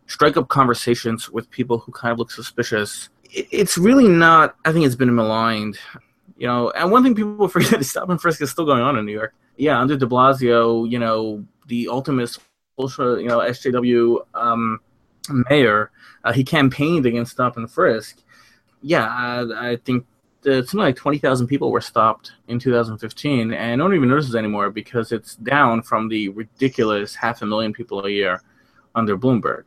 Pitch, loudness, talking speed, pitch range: 120 Hz, -19 LUFS, 185 wpm, 115-140 Hz